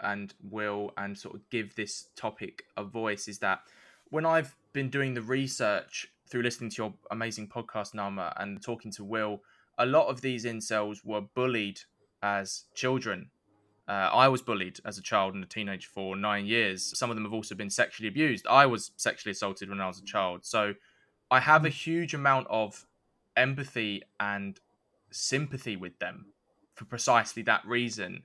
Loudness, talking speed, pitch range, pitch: -30 LUFS, 180 wpm, 100-125 Hz, 110 Hz